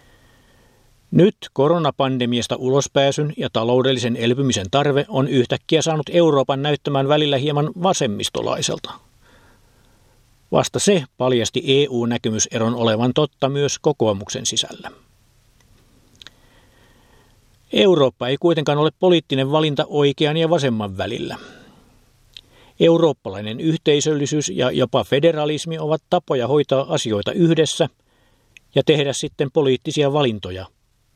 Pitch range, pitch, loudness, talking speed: 120-150 Hz, 130 Hz, -19 LUFS, 95 wpm